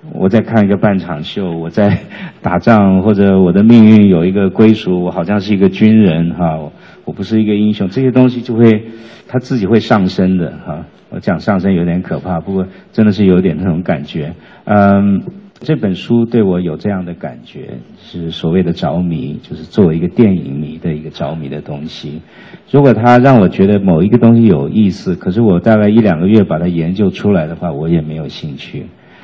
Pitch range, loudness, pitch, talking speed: 90-115 Hz, -11 LUFS, 100 Hz, 300 characters per minute